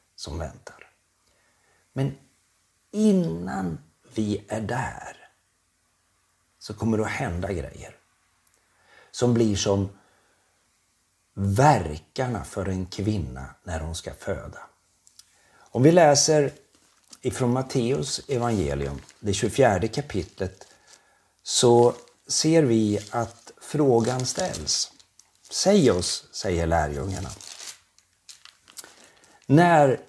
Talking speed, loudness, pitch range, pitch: 90 wpm, -24 LUFS, 90-120 Hz, 100 Hz